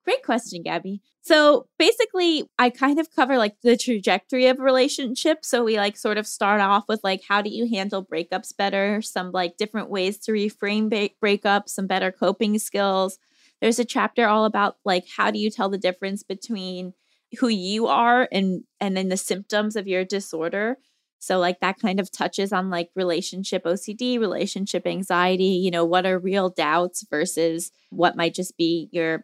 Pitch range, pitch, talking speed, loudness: 185-230 Hz, 200 Hz, 185 wpm, -22 LUFS